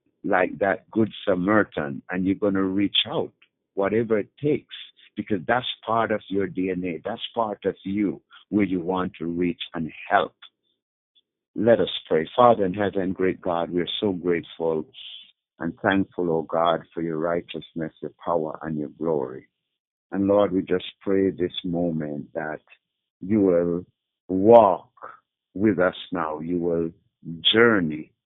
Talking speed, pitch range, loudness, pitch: 150 wpm, 85-100 Hz, -24 LUFS, 95 Hz